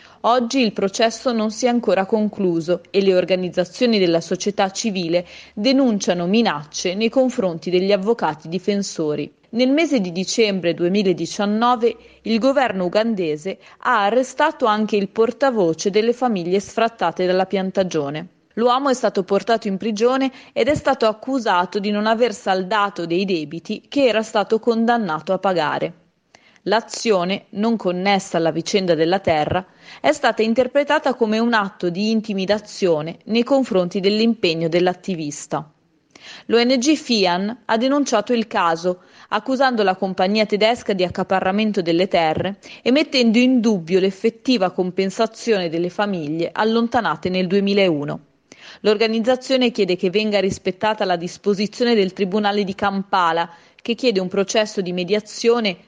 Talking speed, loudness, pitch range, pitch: 130 wpm, -19 LUFS, 185-230 Hz, 205 Hz